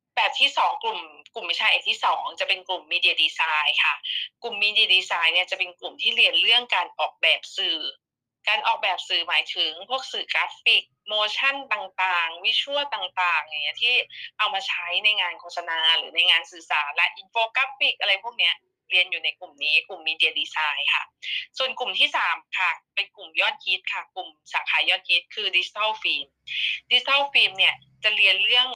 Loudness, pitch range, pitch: -22 LUFS, 175-250 Hz, 190 Hz